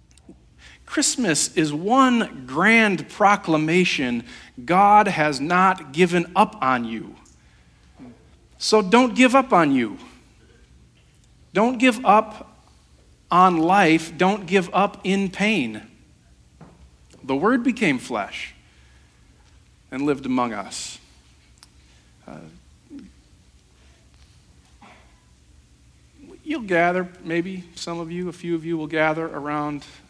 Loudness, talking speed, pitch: -20 LUFS, 100 wpm, 165 Hz